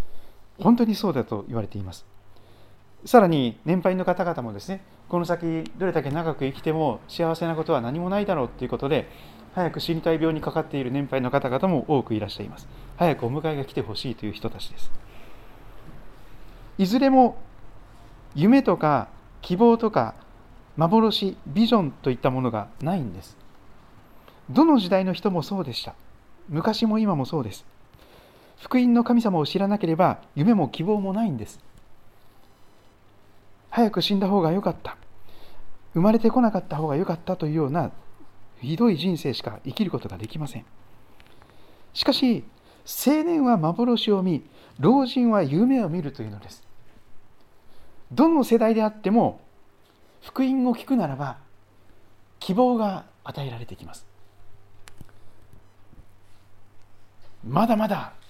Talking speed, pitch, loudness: 285 characters per minute, 140 Hz, -23 LUFS